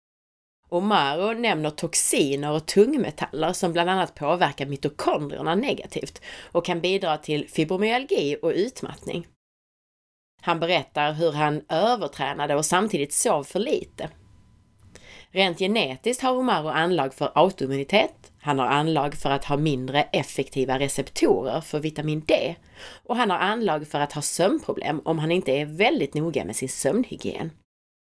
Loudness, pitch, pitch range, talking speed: -24 LUFS, 155 Hz, 145-185 Hz, 135 wpm